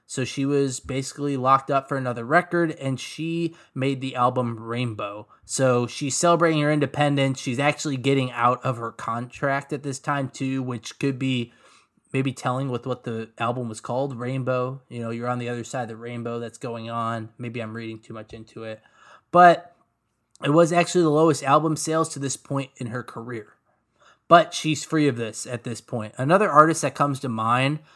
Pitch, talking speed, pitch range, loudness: 130 Hz, 195 wpm, 120-145 Hz, -23 LUFS